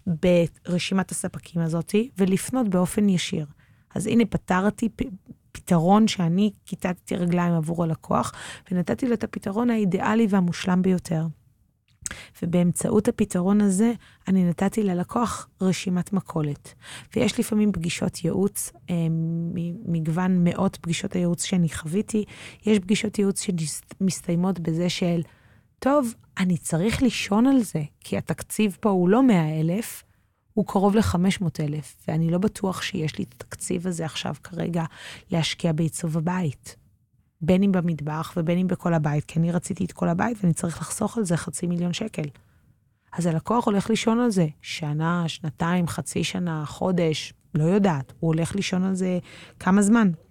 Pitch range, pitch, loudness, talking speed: 165-200 Hz, 180 Hz, -24 LUFS, 135 wpm